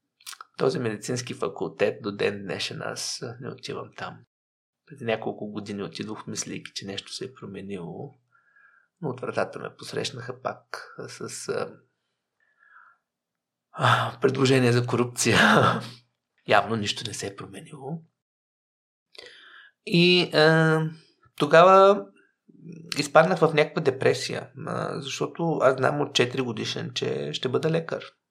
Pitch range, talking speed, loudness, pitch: 115-160 Hz, 120 wpm, -24 LUFS, 135 Hz